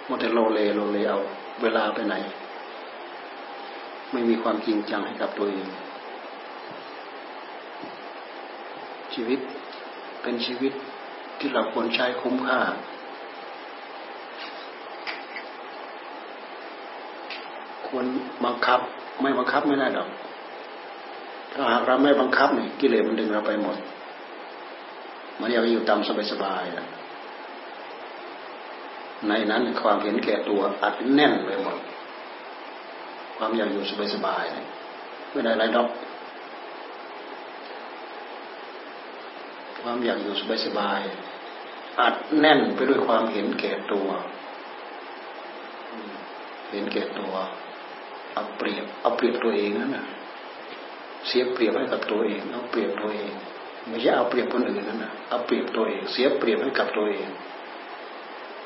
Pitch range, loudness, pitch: 105-125 Hz, -25 LUFS, 115 Hz